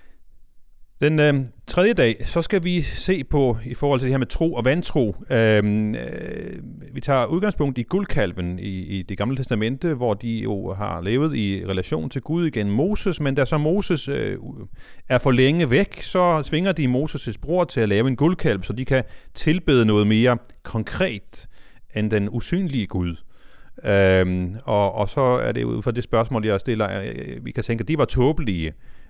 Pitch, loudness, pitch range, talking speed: 125 Hz, -22 LUFS, 105-150 Hz, 190 wpm